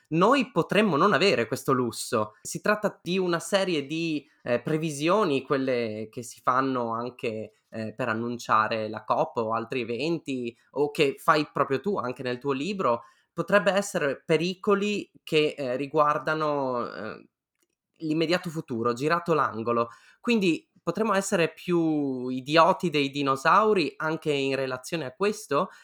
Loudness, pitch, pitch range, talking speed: -26 LUFS, 150 Hz, 125-170 Hz, 135 wpm